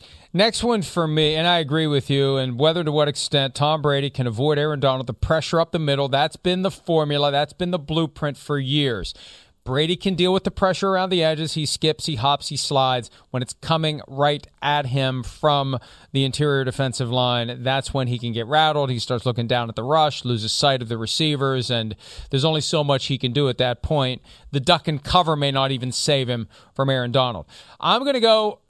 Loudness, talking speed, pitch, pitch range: -21 LUFS, 220 wpm, 140 Hz, 130-160 Hz